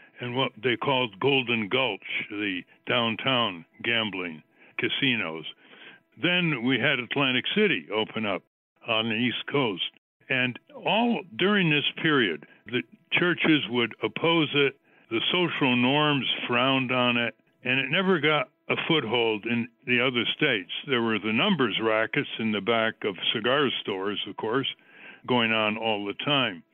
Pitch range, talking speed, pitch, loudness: 110-150 Hz, 145 wpm, 125 Hz, -25 LUFS